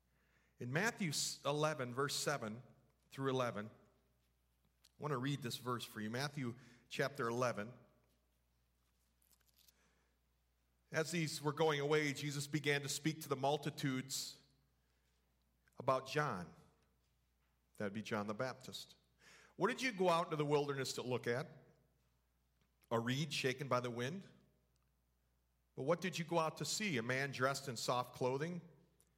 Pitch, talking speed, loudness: 125 Hz, 140 wpm, -40 LUFS